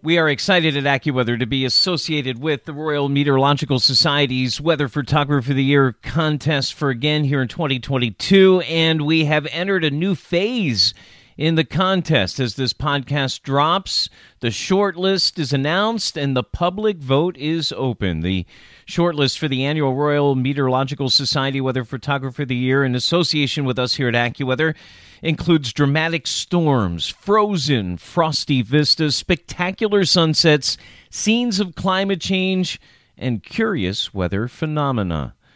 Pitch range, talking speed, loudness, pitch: 130-165 Hz, 140 wpm, -19 LUFS, 145 Hz